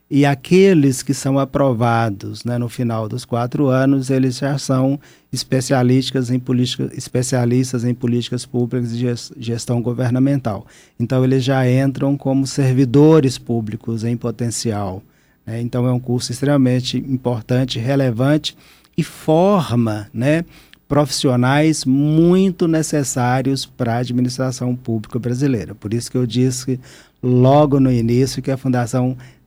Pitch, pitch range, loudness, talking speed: 130 Hz, 120-140 Hz, -18 LUFS, 130 wpm